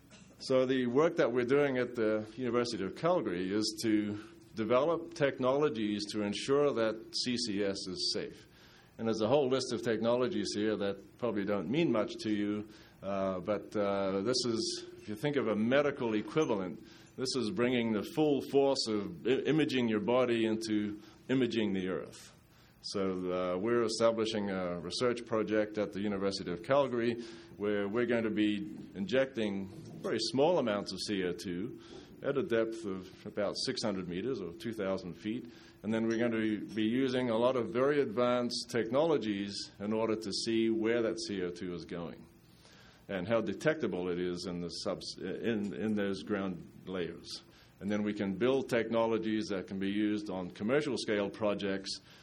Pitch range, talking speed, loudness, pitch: 100-120 Hz, 165 wpm, -33 LUFS, 110 Hz